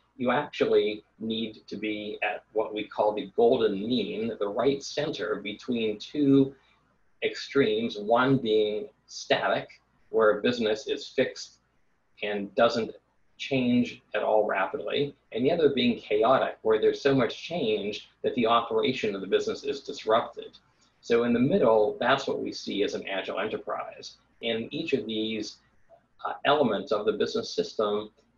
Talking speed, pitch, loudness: 150 wpm, 135 Hz, -27 LUFS